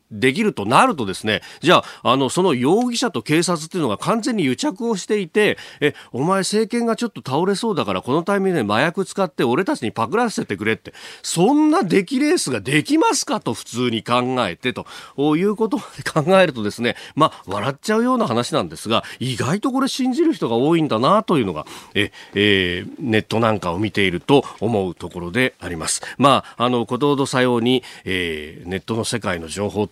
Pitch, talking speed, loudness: 140 Hz, 410 characters per minute, -19 LUFS